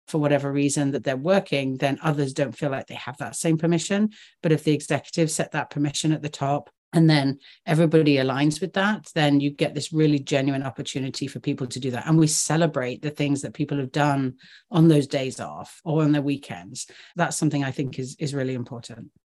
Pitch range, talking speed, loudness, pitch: 140-155 Hz, 215 wpm, -24 LUFS, 145 Hz